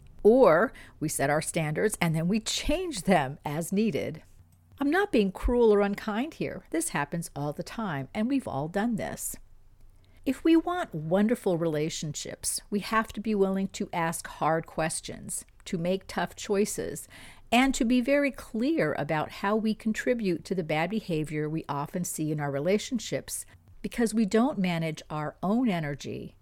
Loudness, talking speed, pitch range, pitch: -28 LUFS, 165 wpm, 160-225 Hz, 195 Hz